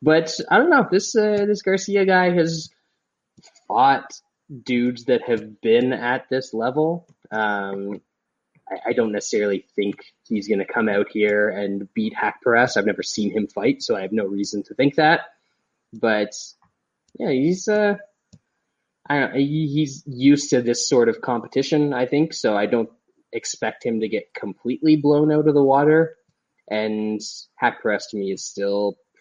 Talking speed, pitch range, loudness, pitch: 170 wpm, 110-160 Hz, -21 LUFS, 135 Hz